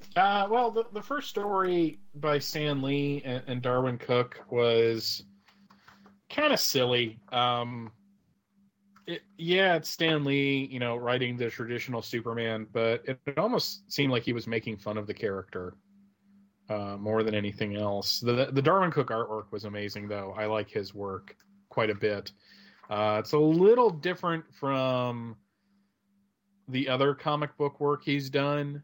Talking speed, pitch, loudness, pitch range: 155 wpm, 135 Hz, -29 LUFS, 115-175 Hz